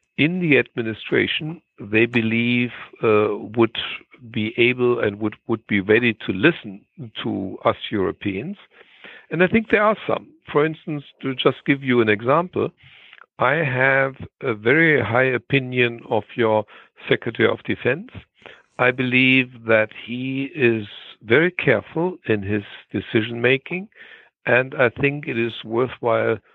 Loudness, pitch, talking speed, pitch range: -20 LUFS, 120 Hz, 140 wpm, 110-135 Hz